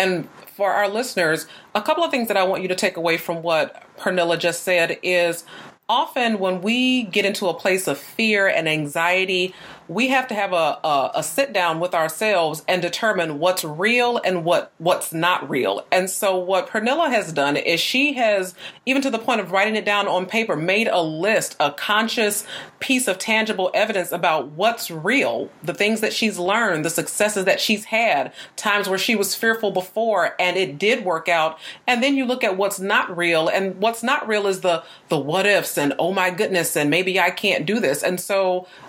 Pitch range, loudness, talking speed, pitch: 175-220 Hz, -20 LUFS, 205 wpm, 190 Hz